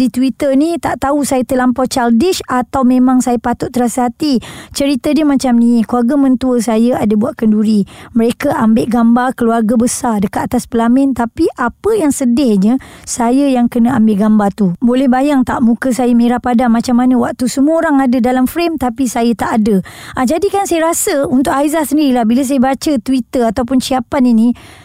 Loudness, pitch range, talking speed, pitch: -12 LUFS, 235-275 Hz, 185 wpm, 250 Hz